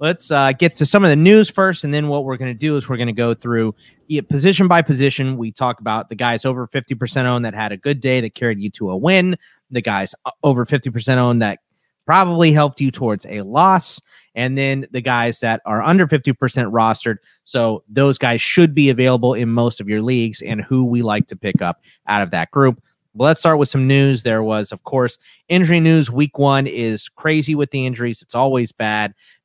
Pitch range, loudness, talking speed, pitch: 115-145 Hz, -17 LUFS, 225 wpm, 130 Hz